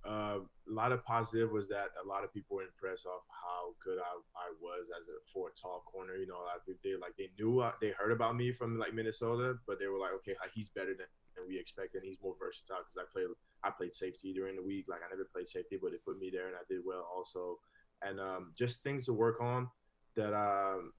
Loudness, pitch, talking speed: -40 LUFS, 115 Hz, 260 wpm